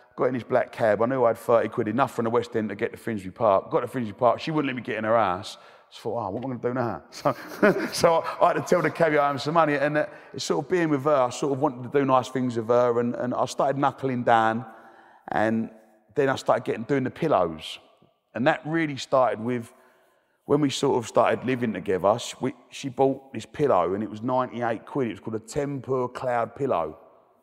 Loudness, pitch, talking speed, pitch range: -25 LUFS, 125 Hz, 255 wpm, 115-140 Hz